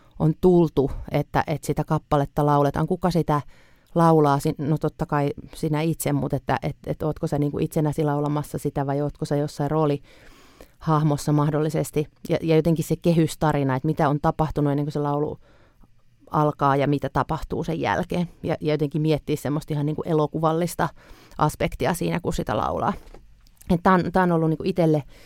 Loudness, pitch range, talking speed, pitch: -23 LUFS, 145-160 Hz, 160 wpm, 150 Hz